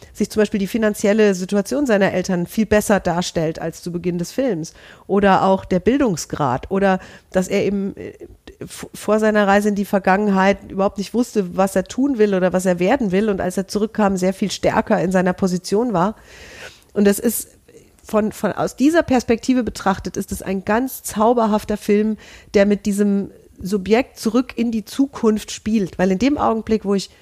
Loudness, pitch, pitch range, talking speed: -19 LUFS, 205 Hz, 190-220 Hz, 185 wpm